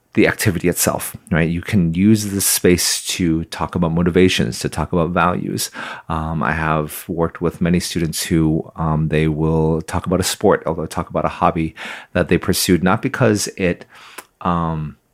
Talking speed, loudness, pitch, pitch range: 175 wpm, -18 LUFS, 85 Hz, 80-90 Hz